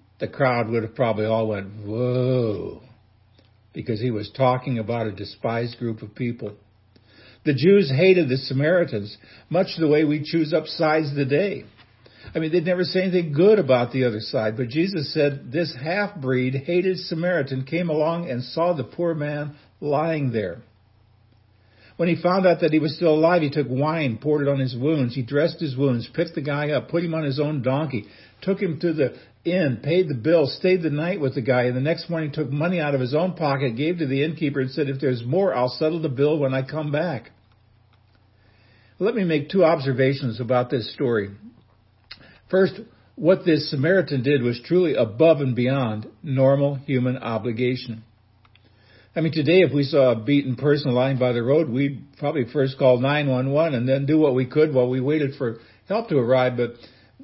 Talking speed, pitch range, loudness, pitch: 195 wpm, 120-160 Hz, -22 LUFS, 135 Hz